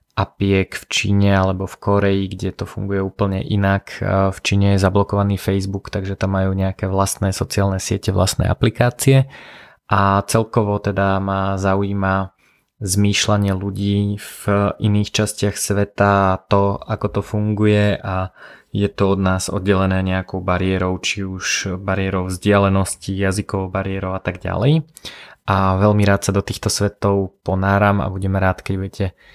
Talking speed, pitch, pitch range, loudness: 140 wpm, 100 Hz, 95-100 Hz, -19 LUFS